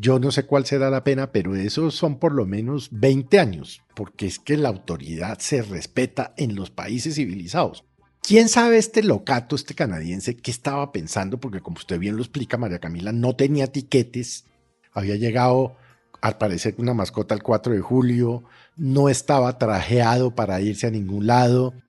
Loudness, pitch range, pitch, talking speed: -22 LUFS, 110-140 Hz, 125 Hz, 175 wpm